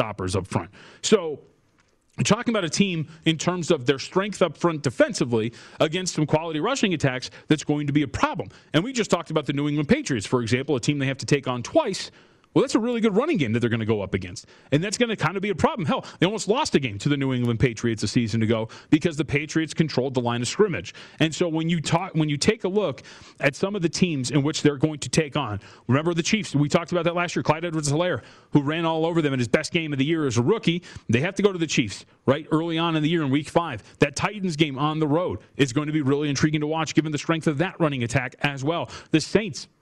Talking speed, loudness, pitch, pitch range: 270 wpm, -24 LUFS, 155 Hz, 135-175 Hz